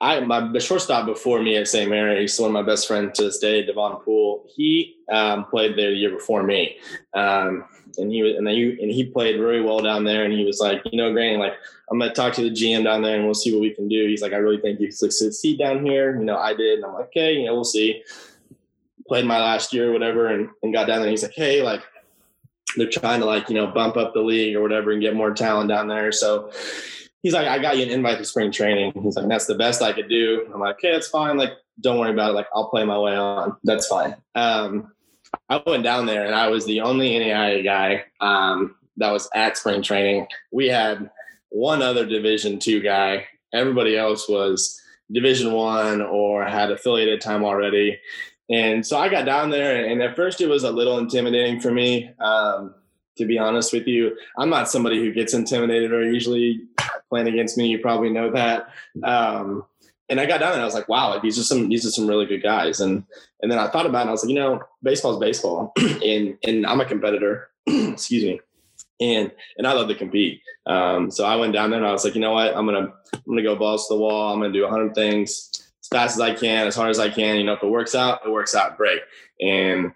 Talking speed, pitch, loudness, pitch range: 245 wpm, 110 Hz, -21 LUFS, 105-120 Hz